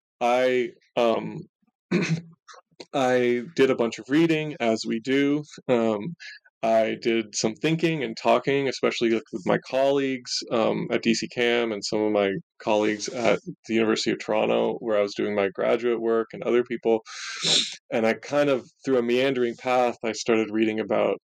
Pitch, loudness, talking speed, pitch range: 120 Hz, -24 LUFS, 165 wpm, 110-140 Hz